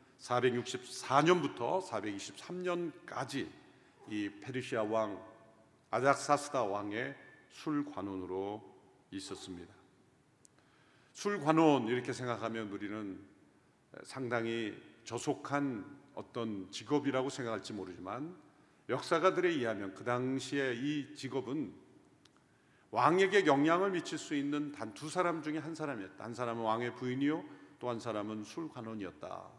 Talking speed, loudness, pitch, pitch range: 250 characters per minute, -36 LUFS, 125 Hz, 110-145 Hz